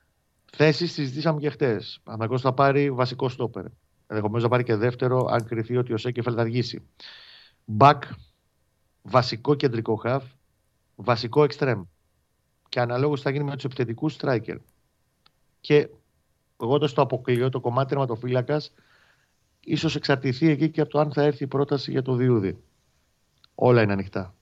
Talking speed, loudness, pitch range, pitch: 145 wpm, -24 LUFS, 115-145 Hz, 125 Hz